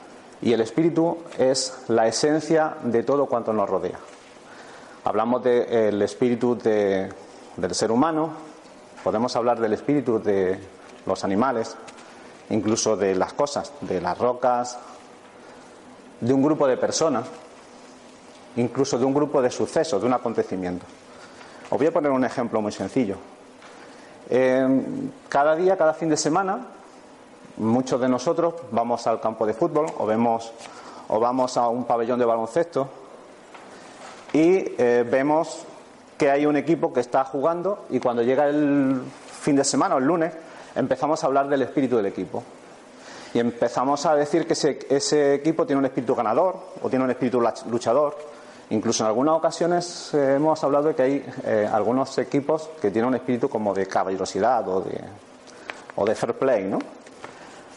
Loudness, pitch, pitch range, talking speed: -23 LUFS, 130 Hz, 115-150 Hz, 155 wpm